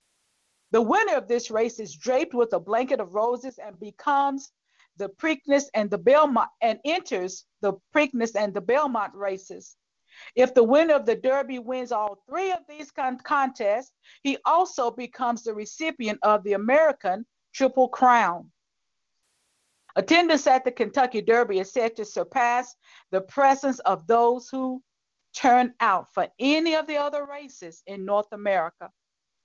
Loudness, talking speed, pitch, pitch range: -24 LUFS, 150 wpm, 245 Hz, 215-280 Hz